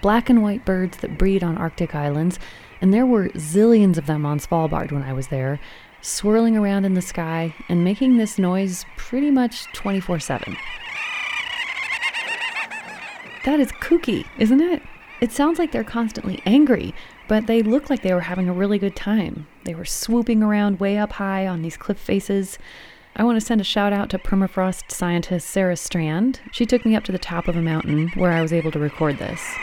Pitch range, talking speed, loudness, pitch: 175-235 Hz, 195 wpm, -21 LUFS, 195 Hz